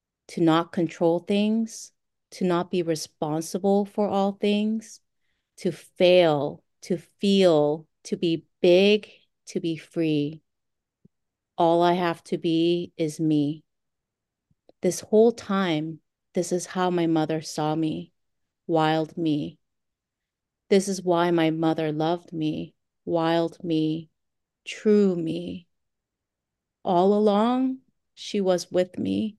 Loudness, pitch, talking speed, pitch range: -24 LUFS, 170 Hz, 115 wpm, 155-195 Hz